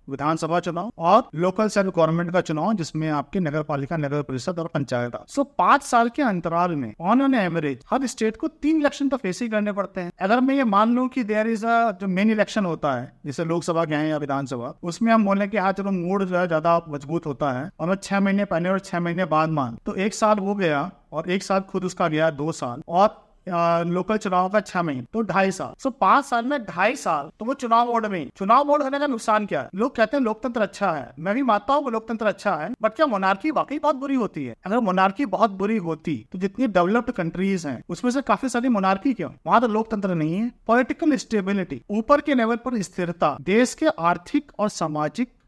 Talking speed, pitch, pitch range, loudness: 230 wpm, 195 Hz, 170-230 Hz, -23 LUFS